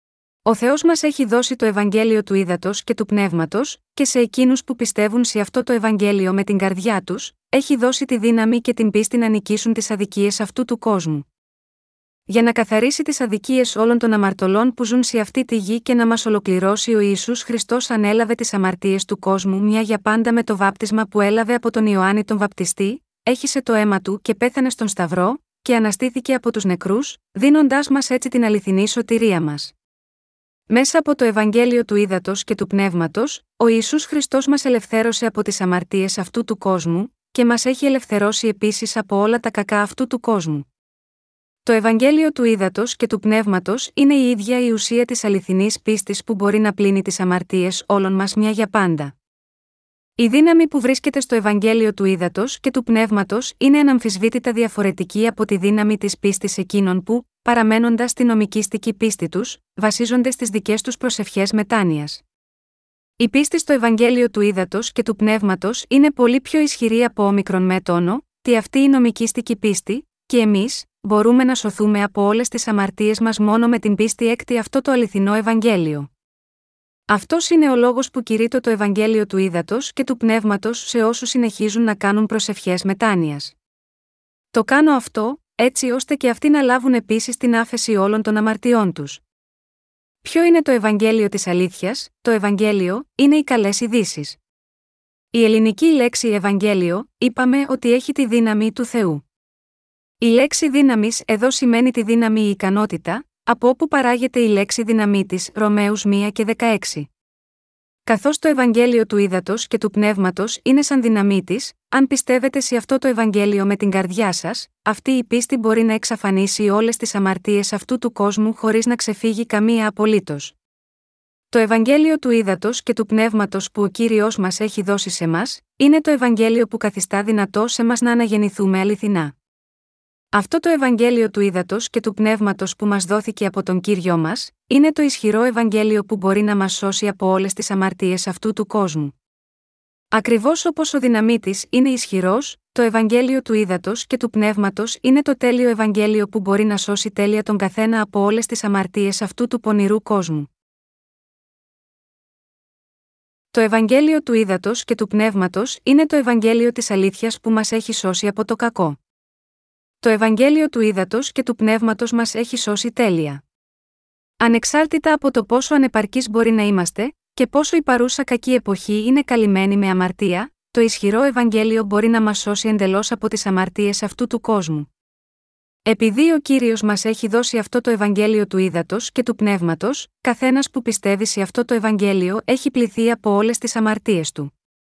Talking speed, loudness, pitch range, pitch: 170 wpm, -18 LUFS, 200-240 Hz, 220 Hz